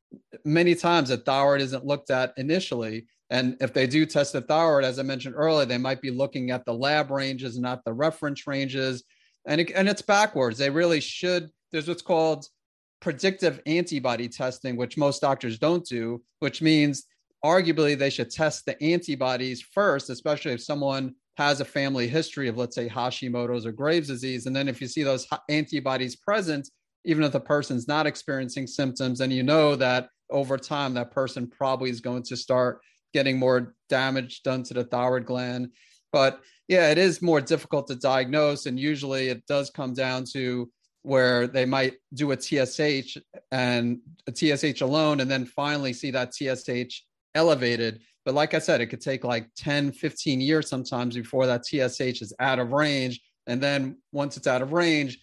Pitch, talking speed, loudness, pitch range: 135 Hz, 180 wpm, -26 LUFS, 125-150 Hz